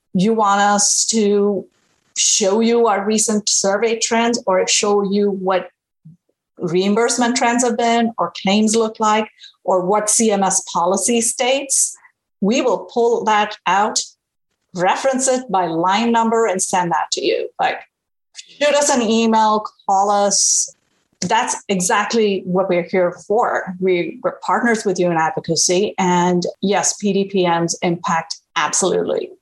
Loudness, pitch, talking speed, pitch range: -17 LUFS, 205 Hz, 135 wpm, 185-230 Hz